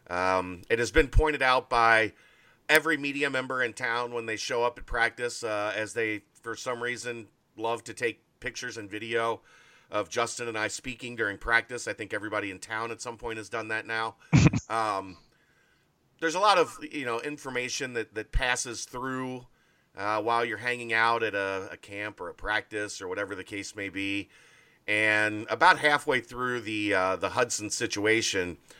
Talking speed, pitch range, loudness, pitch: 185 wpm, 105-125 Hz, -28 LUFS, 115 Hz